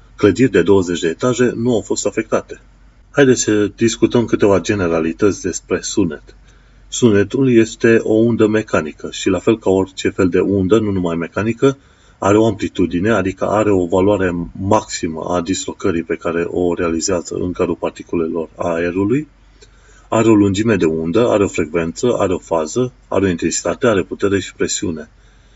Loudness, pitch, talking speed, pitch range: -16 LUFS, 105 Hz, 160 wpm, 90-115 Hz